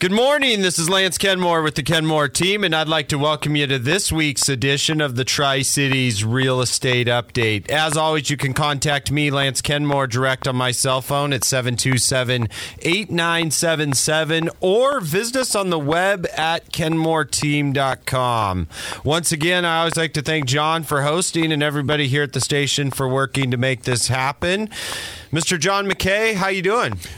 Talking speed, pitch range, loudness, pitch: 170 wpm, 130-165 Hz, -19 LUFS, 150 Hz